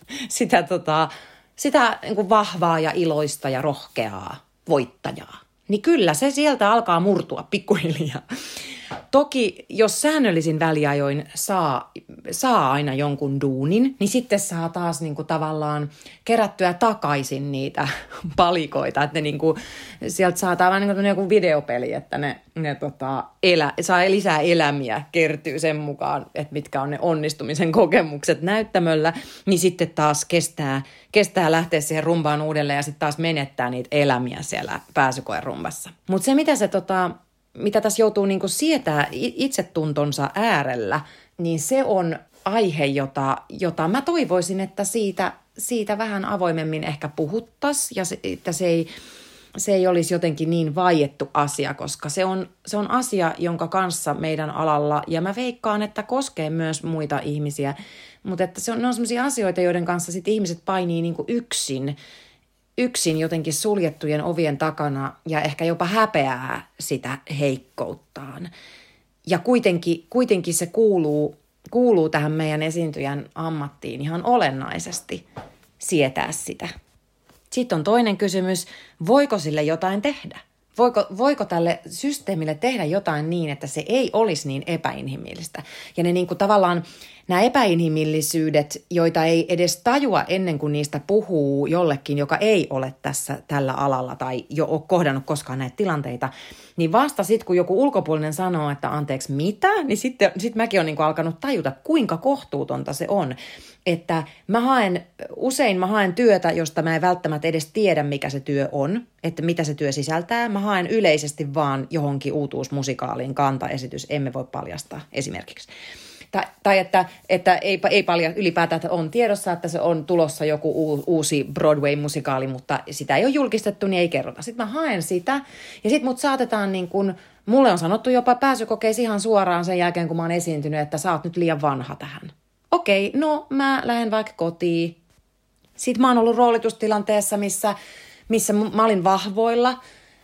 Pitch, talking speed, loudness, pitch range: 170 Hz, 155 wpm, -22 LUFS, 150-210 Hz